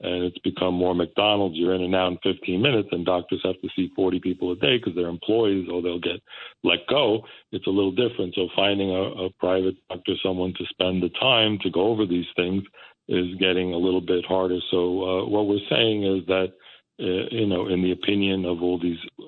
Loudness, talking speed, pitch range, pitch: -24 LUFS, 220 wpm, 90-95 Hz, 90 Hz